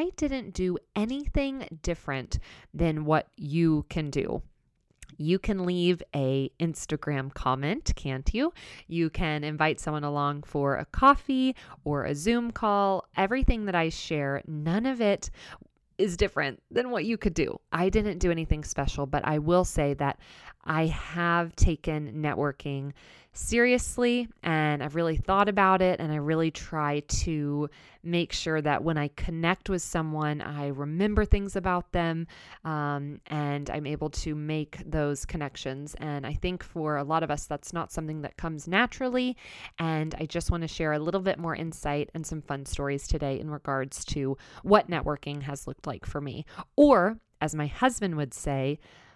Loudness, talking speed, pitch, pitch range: -29 LUFS, 165 wpm, 160 Hz, 145-185 Hz